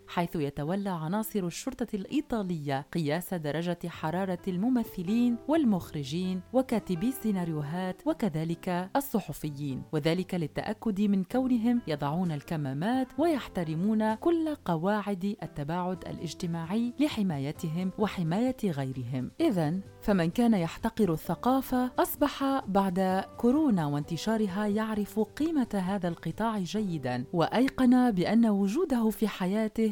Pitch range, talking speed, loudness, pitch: 170-230 Hz, 95 wpm, -30 LUFS, 200 Hz